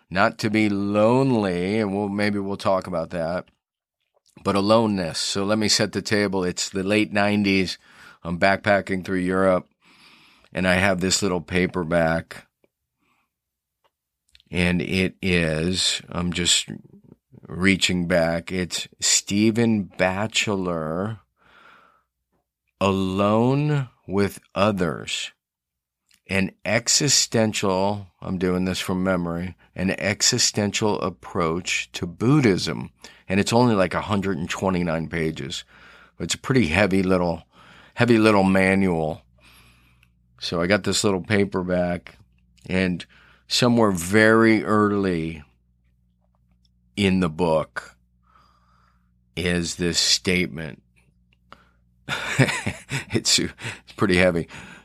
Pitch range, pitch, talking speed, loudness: 80-100 Hz, 95 Hz, 100 wpm, -22 LUFS